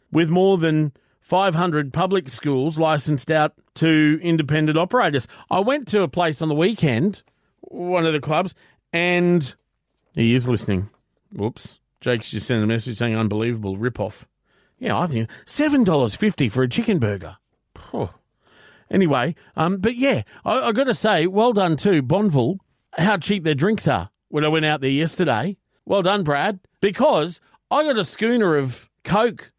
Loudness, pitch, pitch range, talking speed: -21 LUFS, 160 Hz, 135-195 Hz, 160 wpm